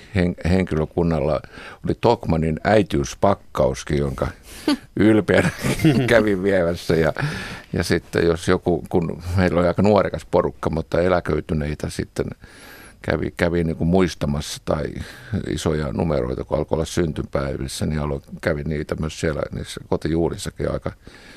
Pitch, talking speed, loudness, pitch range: 85 Hz, 115 wpm, -21 LUFS, 75-90 Hz